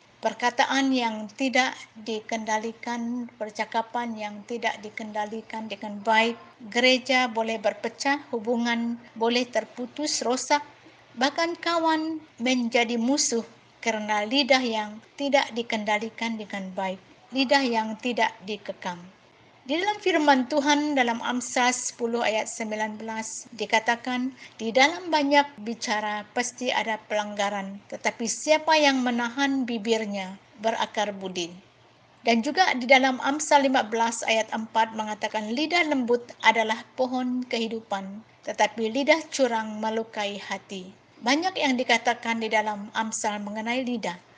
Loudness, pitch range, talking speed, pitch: -25 LUFS, 220-260 Hz, 110 wpm, 230 Hz